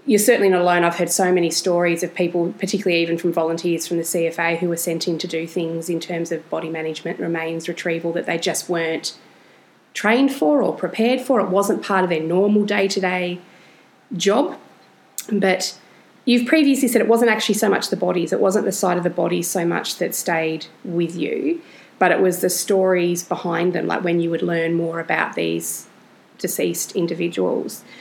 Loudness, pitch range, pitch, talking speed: -20 LUFS, 170-195 Hz, 175 Hz, 195 wpm